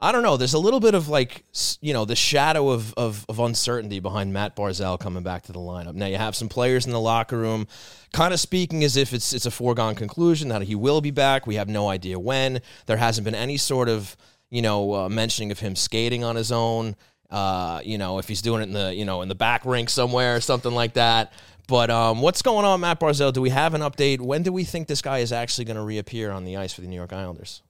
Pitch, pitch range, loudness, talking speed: 115 Hz, 105-130 Hz, -23 LUFS, 260 wpm